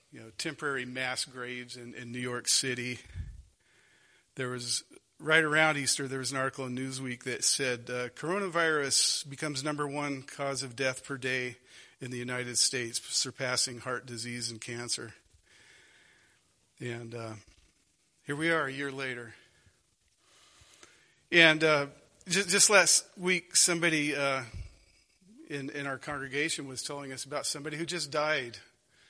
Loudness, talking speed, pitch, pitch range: -29 LUFS, 145 wpm, 135 Hz, 125-150 Hz